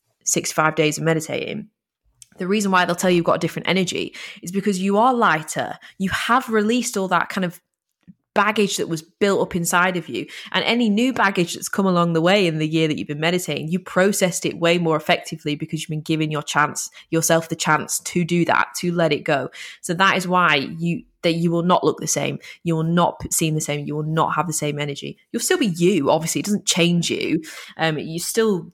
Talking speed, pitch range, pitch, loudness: 235 wpm, 160-190 Hz, 170 Hz, -20 LUFS